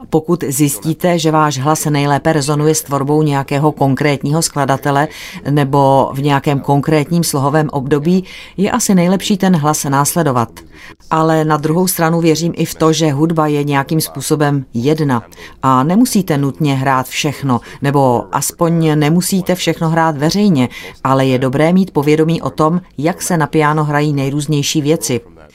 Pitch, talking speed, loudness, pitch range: 150 Hz, 150 wpm, -14 LUFS, 140-160 Hz